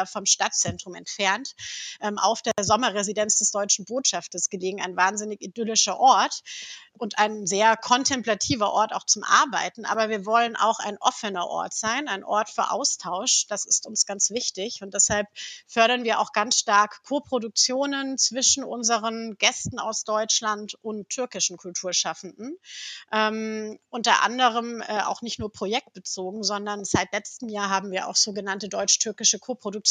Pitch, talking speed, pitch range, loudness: 215 Hz, 150 wpm, 200-230 Hz, -23 LUFS